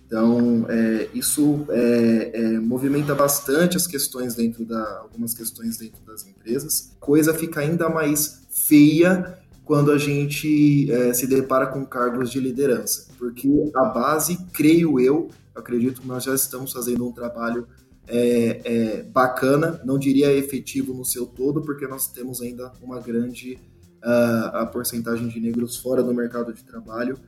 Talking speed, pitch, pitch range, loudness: 155 wpm, 125 Hz, 120-145 Hz, -21 LUFS